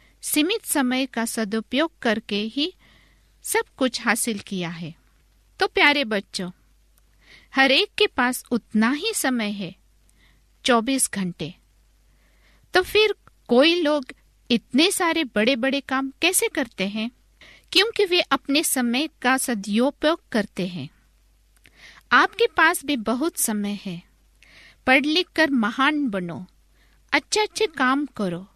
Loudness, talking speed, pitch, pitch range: -22 LUFS, 125 wpm, 265 Hz, 220-320 Hz